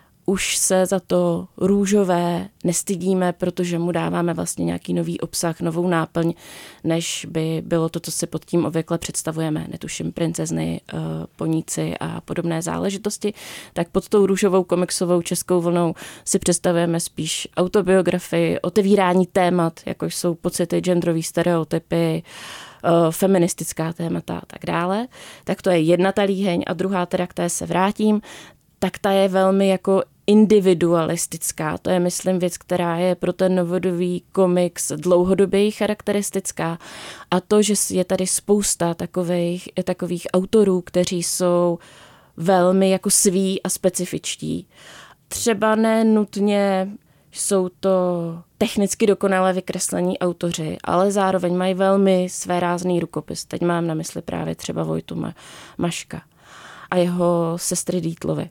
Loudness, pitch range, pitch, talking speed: -21 LUFS, 170-190 Hz, 180 Hz, 130 wpm